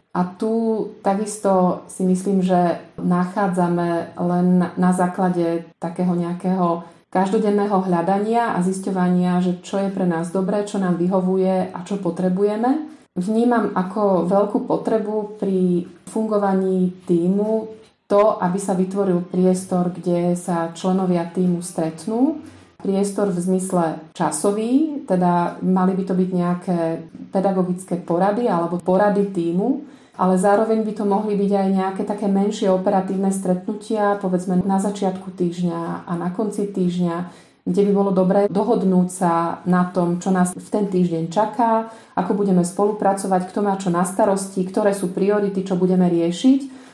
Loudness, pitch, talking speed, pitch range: -20 LUFS, 190 Hz, 140 wpm, 180-205 Hz